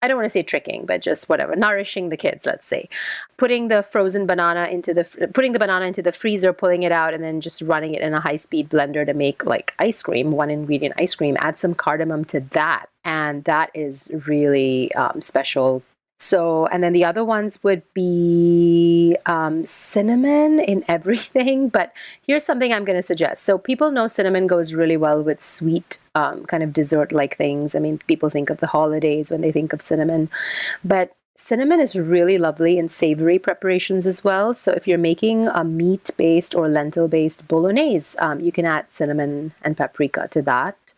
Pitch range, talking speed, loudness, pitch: 155-195 Hz, 200 wpm, -19 LUFS, 170 Hz